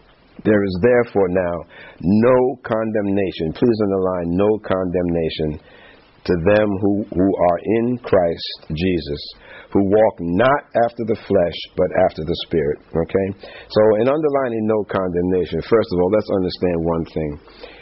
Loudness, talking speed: -19 LUFS, 140 wpm